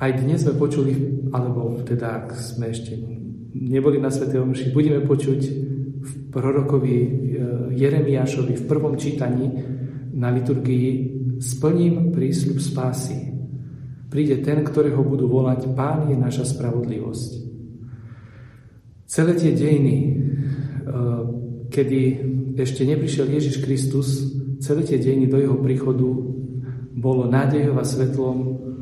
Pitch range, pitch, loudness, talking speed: 125-140 Hz, 130 Hz, -21 LUFS, 110 wpm